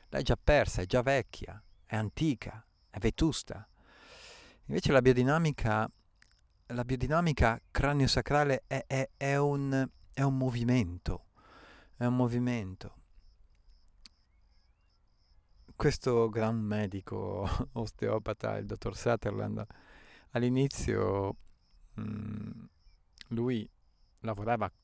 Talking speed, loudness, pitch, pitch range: 90 wpm, -32 LUFS, 115 Hz, 100-130 Hz